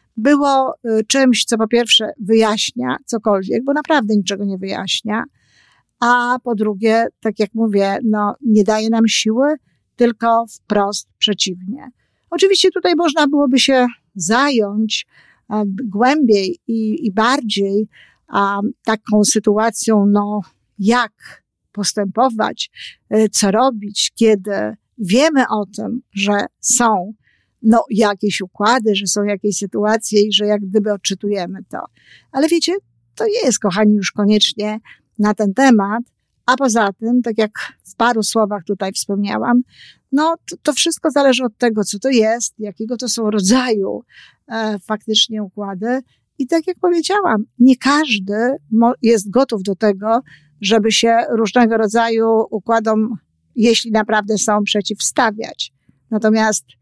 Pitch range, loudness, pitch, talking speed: 205-245 Hz, -16 LUFS, 220 Hz, 130 wpm